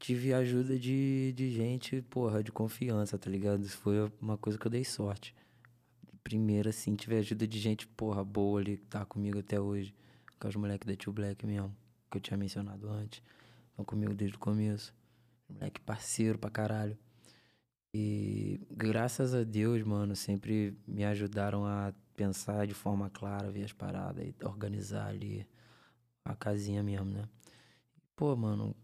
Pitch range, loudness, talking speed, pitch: 100-115 Hz, -36 LUFS, 160 wpm, 105 Hz